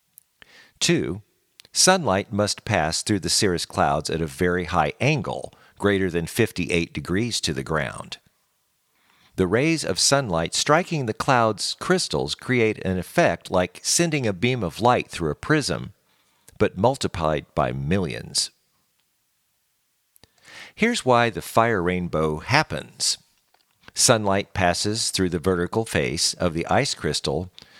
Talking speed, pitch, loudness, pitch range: 130 wpm, 100 Hz, -22 LUFS, 85-125 Hz